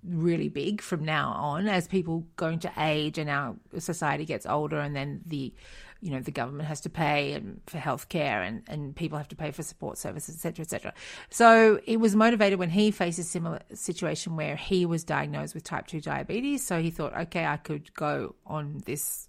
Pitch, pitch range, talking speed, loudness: 165 Hz, 150-185 Hz, 210 wpm, -28 LUFS